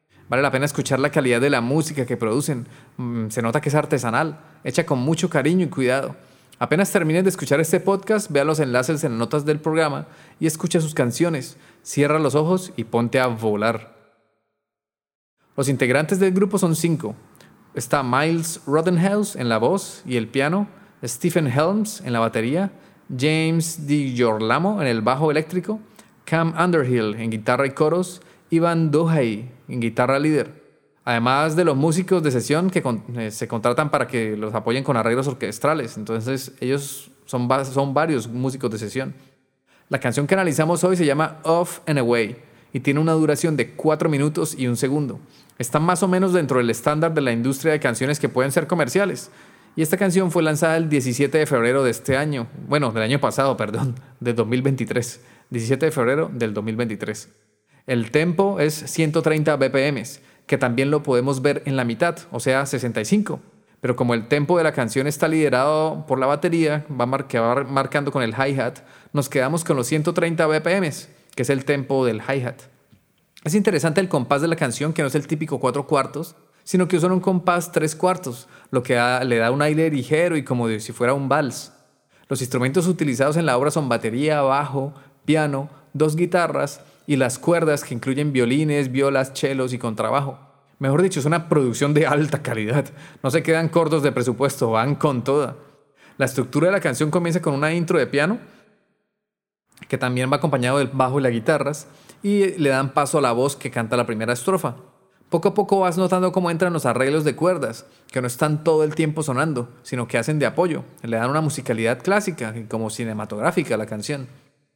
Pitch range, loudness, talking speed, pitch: 125-160 Hz, -21 LUFS, 185 wpm, 145 Hz